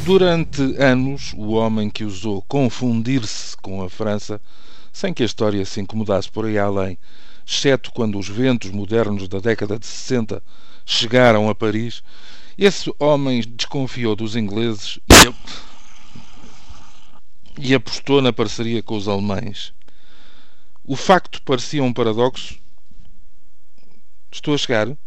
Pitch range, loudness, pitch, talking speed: 105-130 Hz, -18 LUFS, 115 Hz, 120 wpm